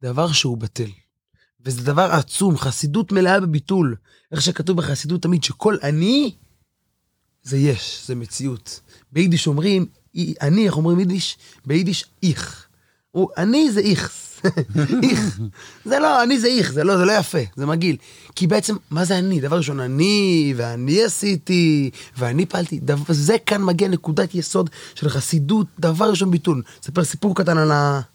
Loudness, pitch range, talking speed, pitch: -19 LUFS, 140-190 Hz, 150 wpm, 165 Hz